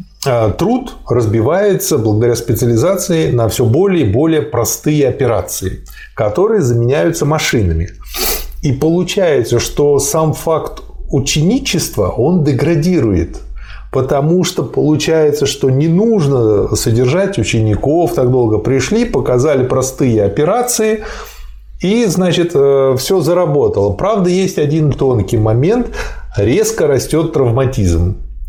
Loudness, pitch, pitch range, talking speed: -13 LUFS, 145 Hz, 120-180 Hz, 100 wpm